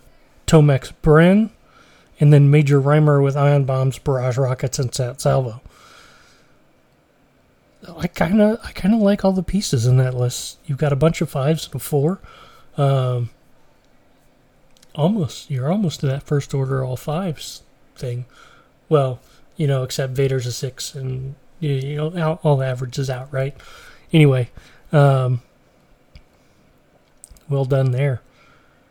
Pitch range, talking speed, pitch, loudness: 130-155 Hz, 135 wpm, 140 Hz, -19 LUFS